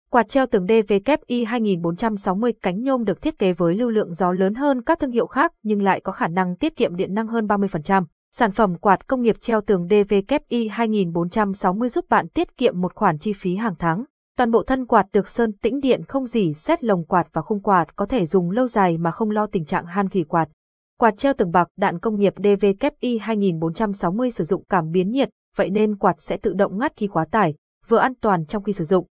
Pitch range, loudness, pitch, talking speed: 185-235 Hz, -21 LUFS, 210 Hz, 225 wpm